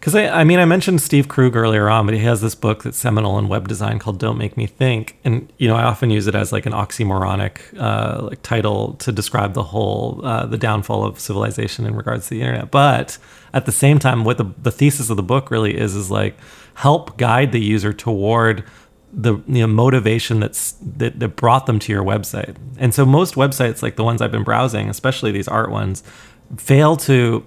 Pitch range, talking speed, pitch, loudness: 105-130 Hz, 225 wpm, 115 Hz, -17 LUFS